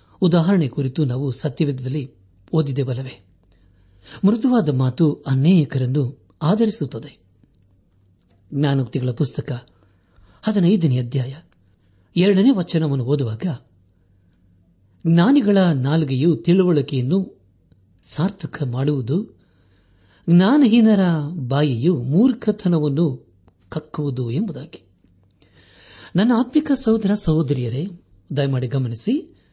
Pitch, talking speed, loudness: 140 Hz, 65 wpm, -19 LUFS